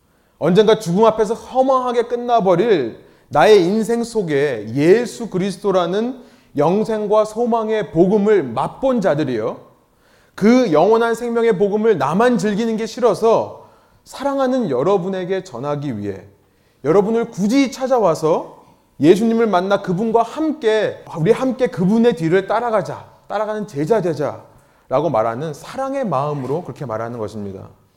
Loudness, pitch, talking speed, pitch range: -17 LUFS, 215 Hz, 305 characters per minute, 160-230 Hz